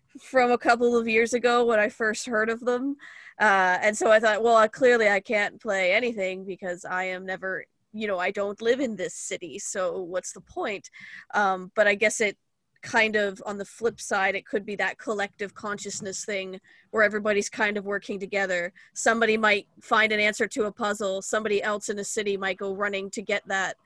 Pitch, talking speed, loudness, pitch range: 210 Hz, 210 wpm, -25 LUFS, 195-225 Hz